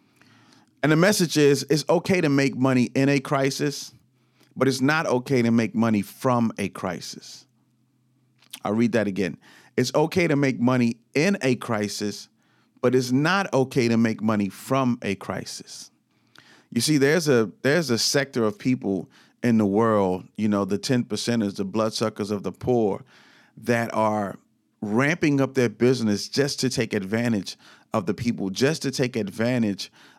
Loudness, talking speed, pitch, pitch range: -23 LUFS, 165 wpm, 120 Hz, 110-135 Hz